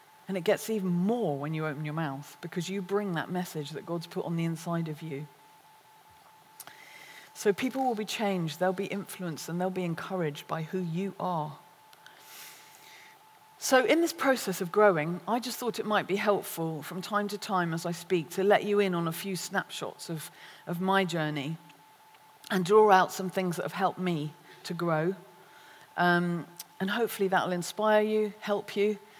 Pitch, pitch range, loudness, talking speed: 185 Hz, 170-210 Hz, -30 LUFS, 185 wpm